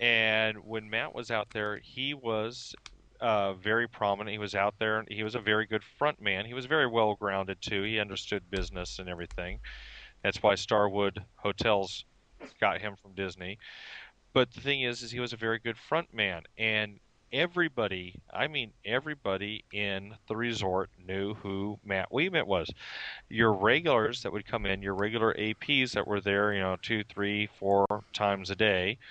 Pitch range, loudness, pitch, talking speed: 100-115 Hz, -31 LUFS, 105 Hz, 175 wpm